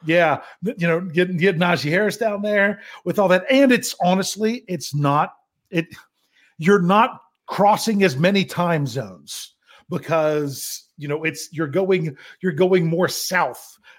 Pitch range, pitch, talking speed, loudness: 165-200 Hz, 180 Hz, 150 wpm, -20 LUFS